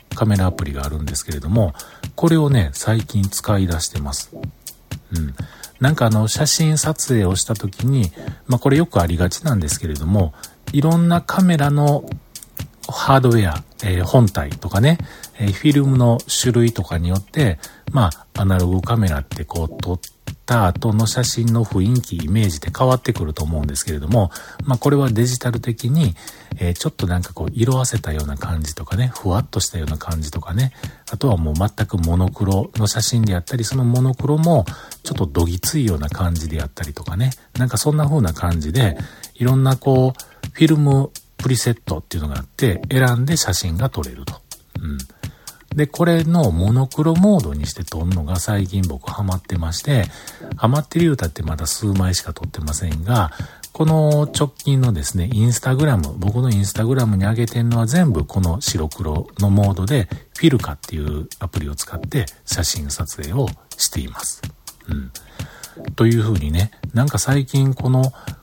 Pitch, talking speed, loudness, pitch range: 110 Hz, 370 characters per minute, -19 LUFS, 90-130 Hz